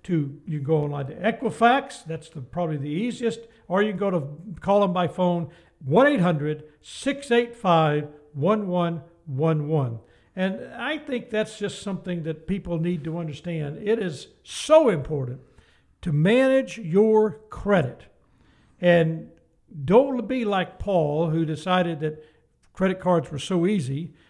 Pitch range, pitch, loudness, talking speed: 155-210 Hz, 175 Hz, -24 LUFS, 140 wpm